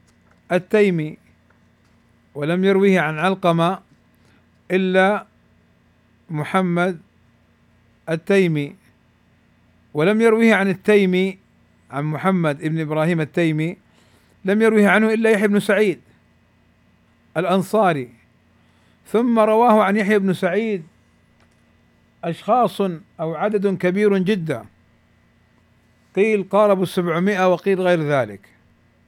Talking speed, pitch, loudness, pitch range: 85 wpm, 165 Hz, -19 LUFS, 115-195 Hz